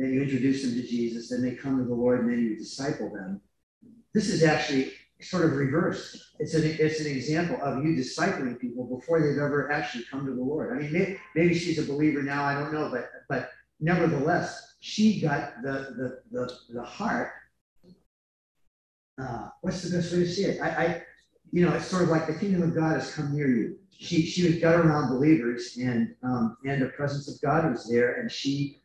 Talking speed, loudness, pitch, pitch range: 210 wpm, -27 LUFS, 145 Hz, 125-165 Hz